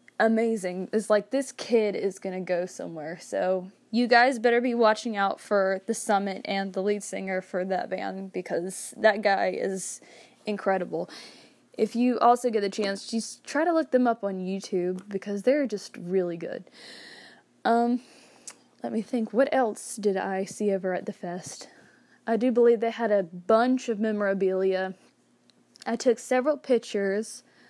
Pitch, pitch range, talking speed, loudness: 210 Hz, 190-235 Hz, 165 wpm, -27 LUFS